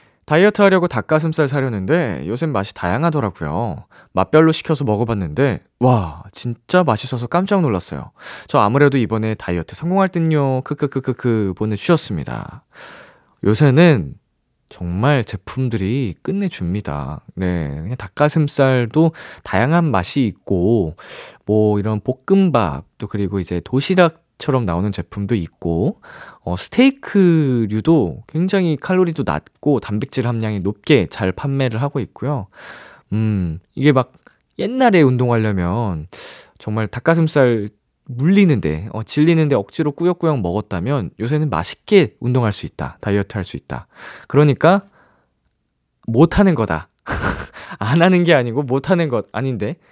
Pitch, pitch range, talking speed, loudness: 125 Hz, 105-155 Hz, 295 characters per minute, -18 LUFS